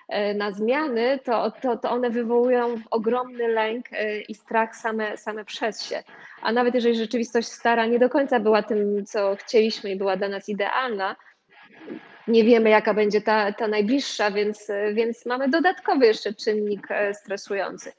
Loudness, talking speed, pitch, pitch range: -23 LUFS, 155 wpm, 225 Hz, 210-240 Hz